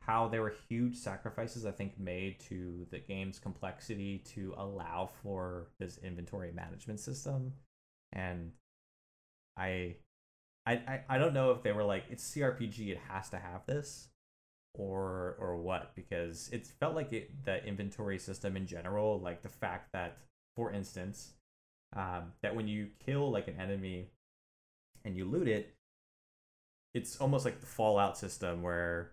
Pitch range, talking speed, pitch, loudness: 90-115 Hz, 150 wpm, 100 Hz, -38 LUFS